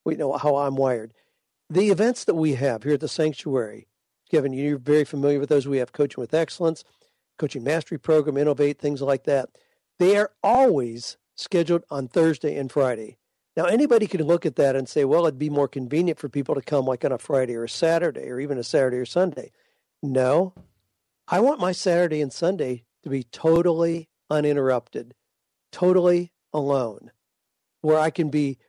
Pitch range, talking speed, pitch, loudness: 135-170 Hz, 180 wpm, 145 Hz, -23 LUFS